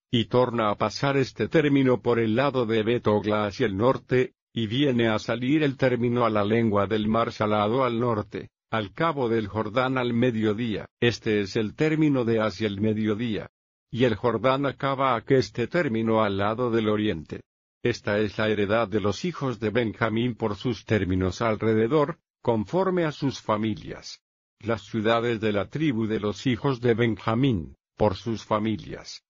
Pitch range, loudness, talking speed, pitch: 110-125 Hz, -25 LUFS, 170 wpm, 115 Hz